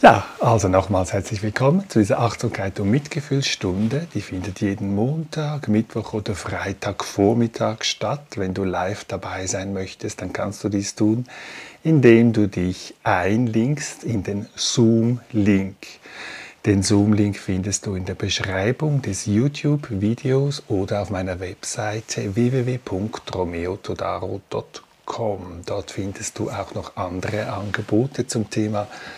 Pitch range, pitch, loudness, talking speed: 100-115 Hz, 105 Hz, -22 LUFS, 120 wpm